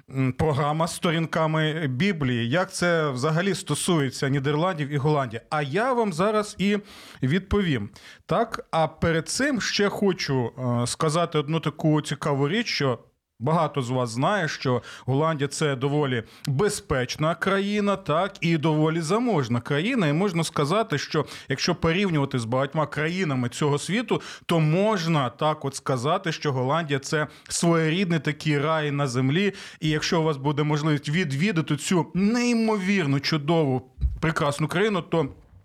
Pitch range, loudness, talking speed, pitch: 140-180 Hz, -24 LUFS, 135 wpm, 155 Hz